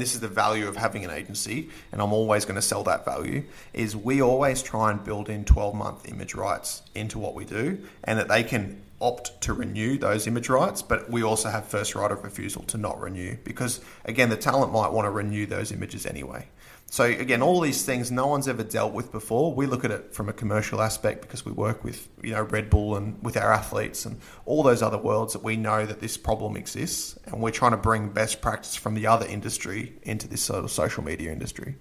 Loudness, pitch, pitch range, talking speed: -26 LUFS, 110 Hz, 105-120 Hz, 235 wpm